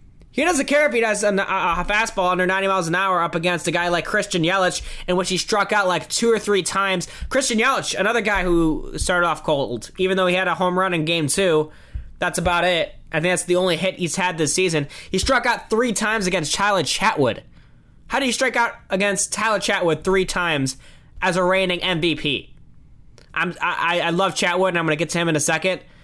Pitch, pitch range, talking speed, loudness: 185 Hz, 170-200 Hz, 225 wpm, -20 LUFS